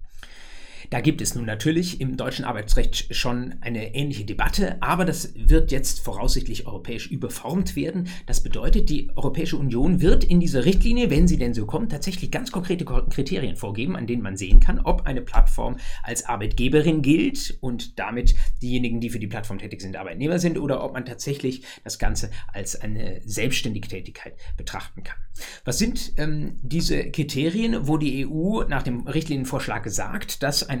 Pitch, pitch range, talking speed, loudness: 130 Hz, 115-160 Hz, 170 wpm, -25 LUFS